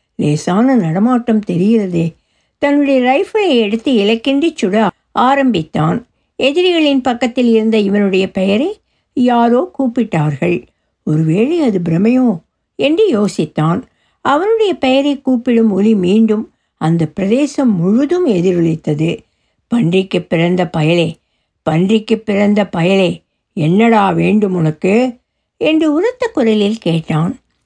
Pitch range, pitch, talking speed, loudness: 180-255 Hz, 215 Hz, 95 wpm, -13 LUFS